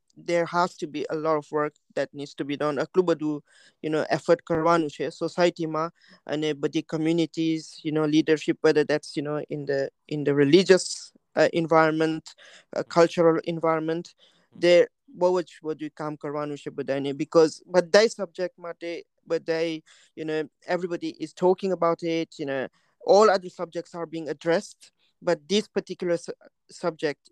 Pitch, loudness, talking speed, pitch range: 160 Hz, -25 LUFS, 155 wpm, 155-170 Hz